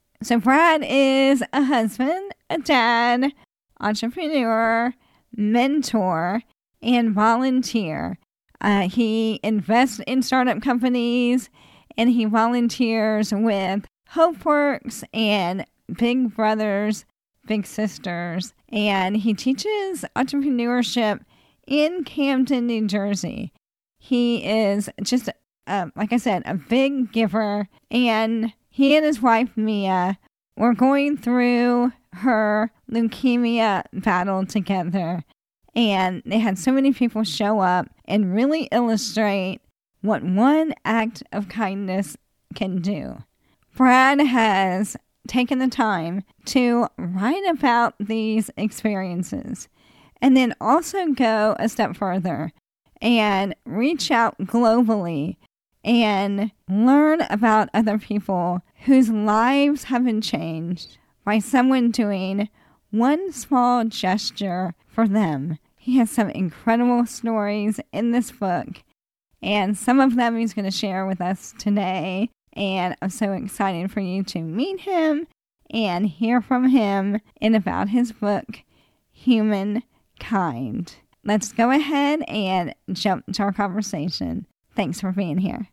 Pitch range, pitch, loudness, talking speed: 200-250 Hz, 225 Hz, -21 LUFS, 115 wpm